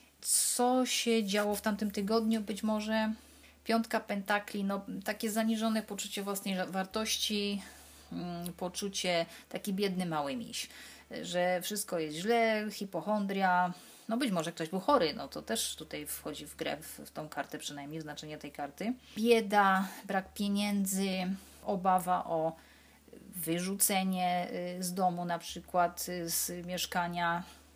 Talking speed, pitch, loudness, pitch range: 130 wpm, 195 Hz, -33 LUFS, 175-215 Hz